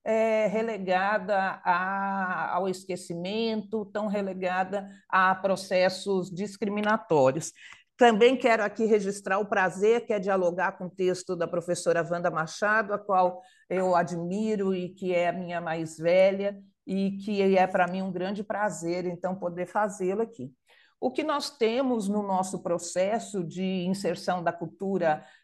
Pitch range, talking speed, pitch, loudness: 180-210 Hz, 140 wpm, 190 Hz, -27 LUFS